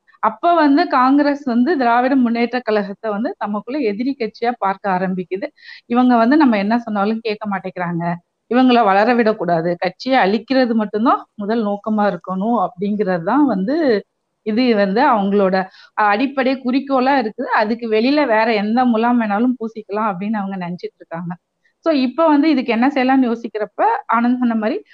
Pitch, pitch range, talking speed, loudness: 230 Hz, 205-260 Hz, 140 wpm, -17 LUFS